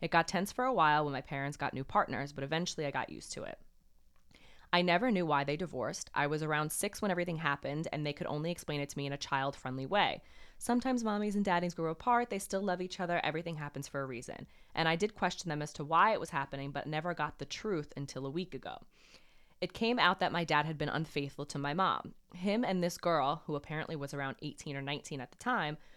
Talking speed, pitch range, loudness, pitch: 245 wpm, 140-180 Hz, -34 LUFS, 155 Hz